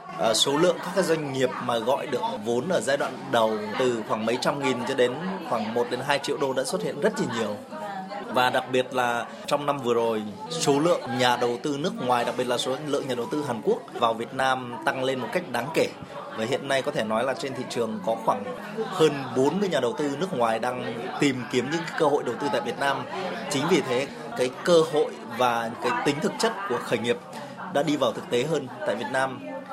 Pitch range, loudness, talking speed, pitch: 120-150 Hz, -26 LUFS, 240 wpm, 130 Hz